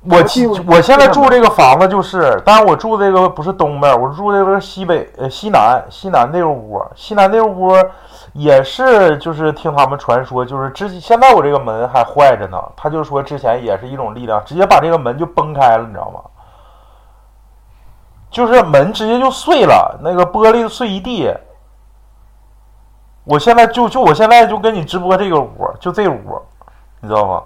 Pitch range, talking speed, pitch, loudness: 140-220 Hz, 275 characters per minute, 185 Hz, -11 LUFS